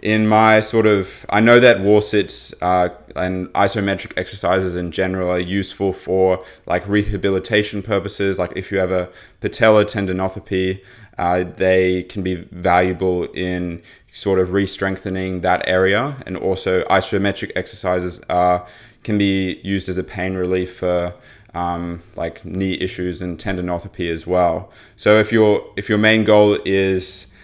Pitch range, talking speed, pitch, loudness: 90-100 Hz, 150 wpm, 95 Hz, -18 LUFS